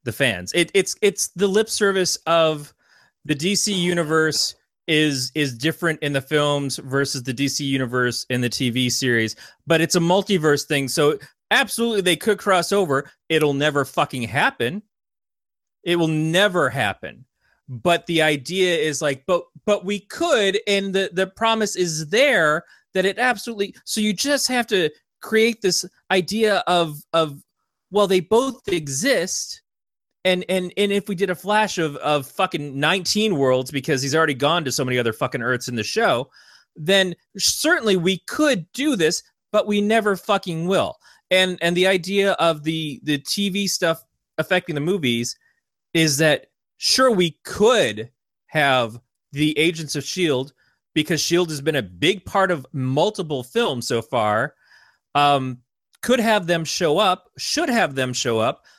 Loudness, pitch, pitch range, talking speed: -20 LUFS, 170 Hz, 145-200 Hz, 160 wpm